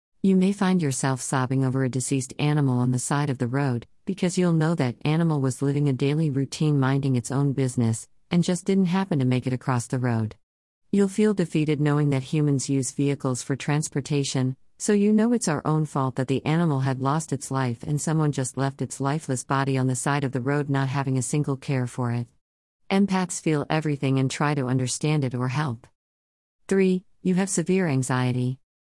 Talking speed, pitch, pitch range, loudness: 205 wpm, 140 Hz, 130-155 Hz, -24 LUFS